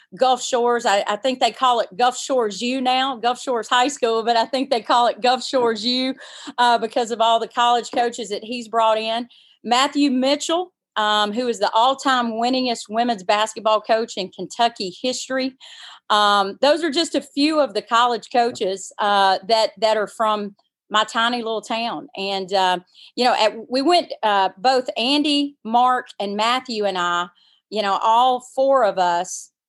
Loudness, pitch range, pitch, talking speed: -20 LUFS, 215-255 Hz, 235 Hz, 180 wpm